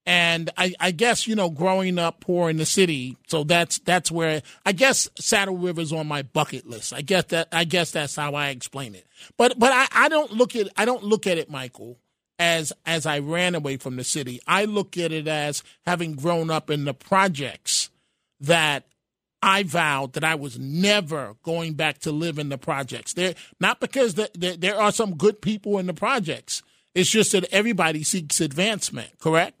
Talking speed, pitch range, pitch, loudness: 205 wpm, 150-195 Hz, 170 Hz, -22 LUFS